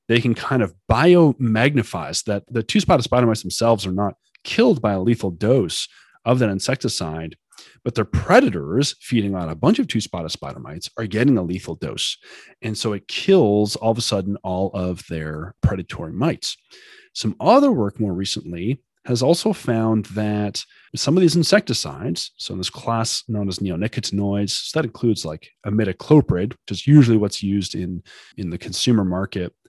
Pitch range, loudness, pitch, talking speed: 95-125 Hz, -20 LUFS, 110 Hz, 175 wpm